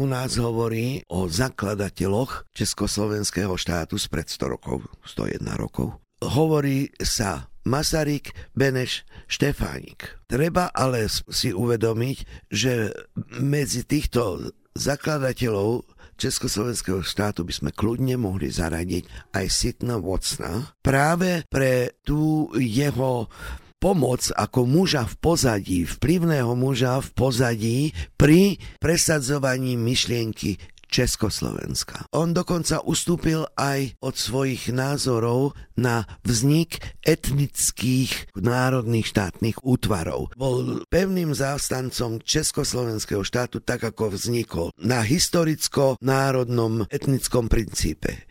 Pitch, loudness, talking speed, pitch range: 125 Hz, -24 LUFS, 95 wpm, 105-140 Hz